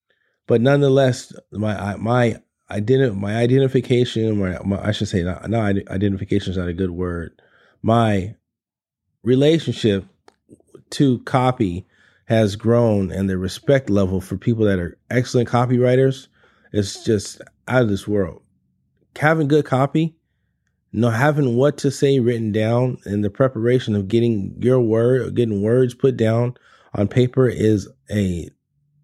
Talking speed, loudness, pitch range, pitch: 135 wpm, -19 LUFS, 100-130 Hz, 115 Hz